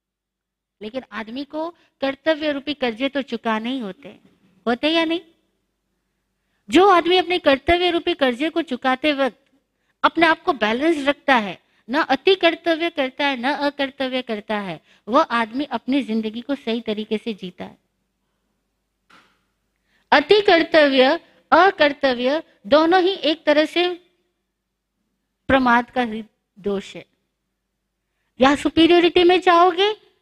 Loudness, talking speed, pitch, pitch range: -19 LUFS, 125 wpm, 280 Hz, 240-330 Hz